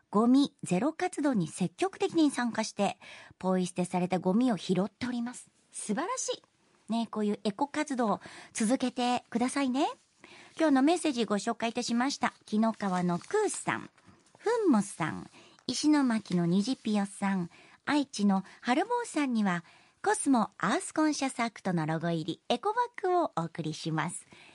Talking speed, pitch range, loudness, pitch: 330 characters per minute, 190-290 Hz, -30 LUFS, 235 Hz